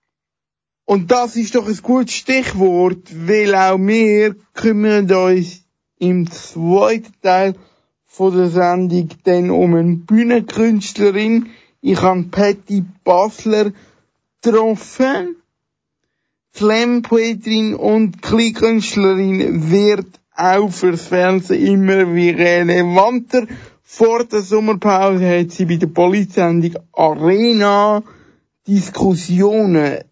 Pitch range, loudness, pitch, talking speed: 180-220 Hz, -14 LUFS, 195 Hz, 95 wpm